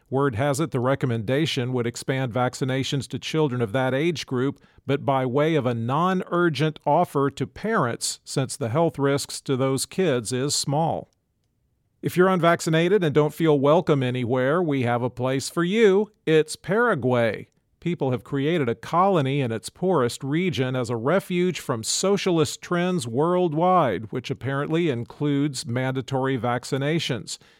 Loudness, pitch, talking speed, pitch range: -23 LUFS, 140 Hz, 150 wpm, 130-165 Hz